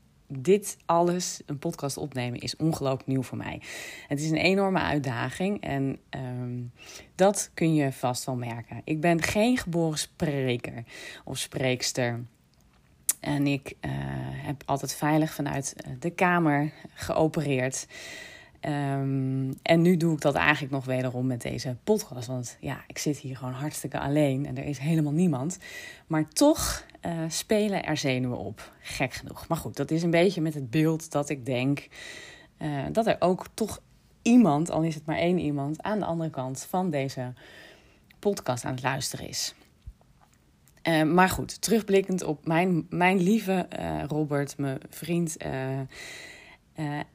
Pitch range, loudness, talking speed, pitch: 130-170 Hz, -28 LUFS, 155 wpm, 150 Hz